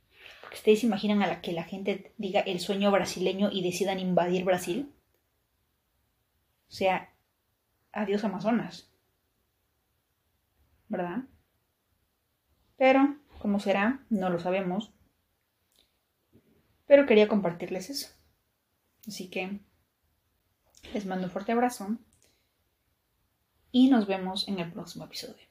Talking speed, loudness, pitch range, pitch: 105 wpm, -28 LUFS, 180-215 Hz, 195 Hz